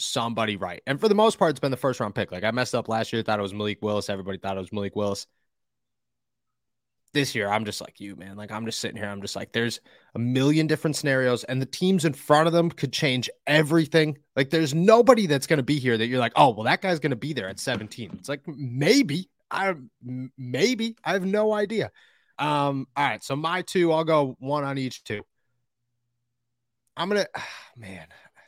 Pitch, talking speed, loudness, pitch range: 130 Hz, 220 wpm, -24 LUFS, 115-160 Hz